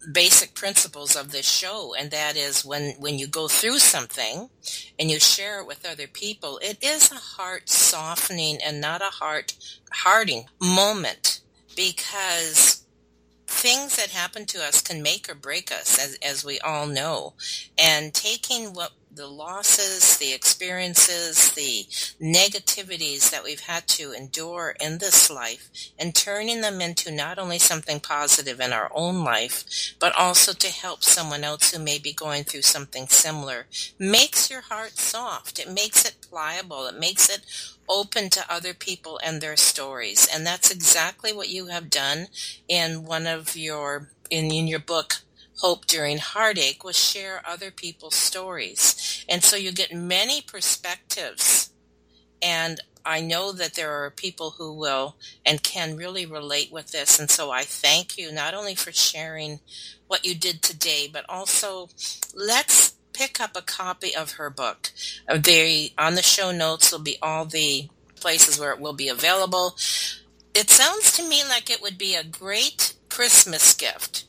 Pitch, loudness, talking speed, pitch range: 165 Hz, -20 LUFS, 165 wpm, 150-190 Hz